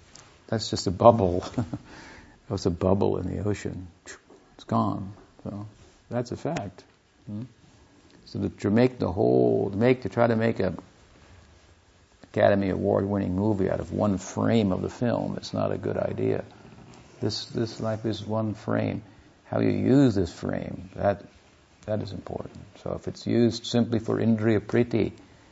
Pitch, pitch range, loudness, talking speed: 100 Hz, 95-115 Hz, -26 LUFS, 165 wpm